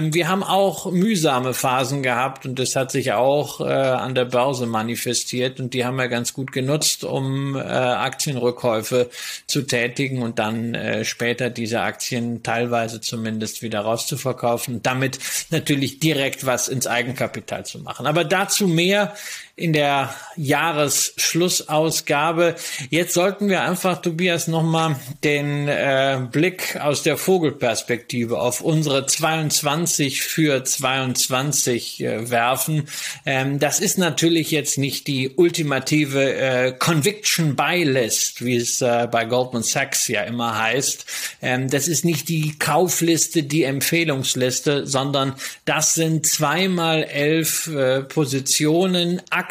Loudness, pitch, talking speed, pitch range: -20 LUFS, 140 Hz, 130 wpm, 125-160 Hz